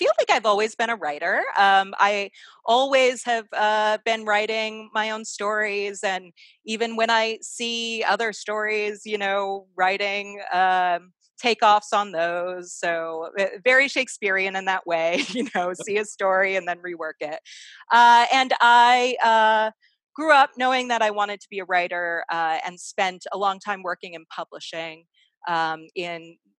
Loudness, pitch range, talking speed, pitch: -22 LUFS, 180-225 Hz, 160 wpm, 205 Hz